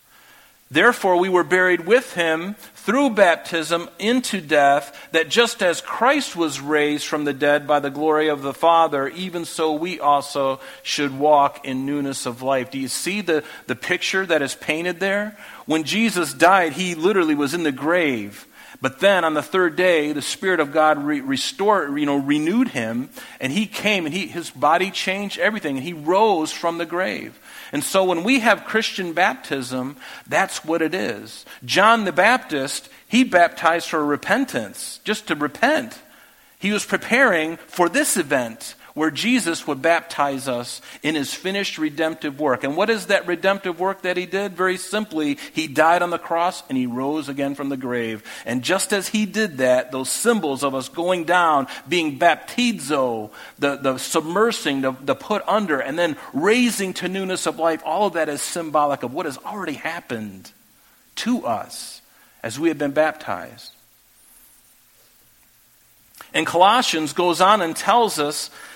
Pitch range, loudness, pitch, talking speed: 145-195 Hz, -20 LUFS, 170 Hz, 170 wpm